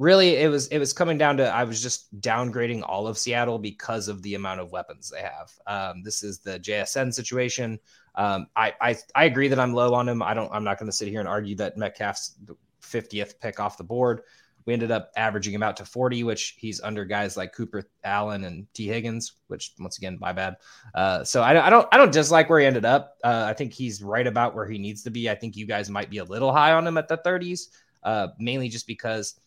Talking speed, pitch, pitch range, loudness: 245 wpm, 115 Hz, 105-125 Hz, -24 LUFS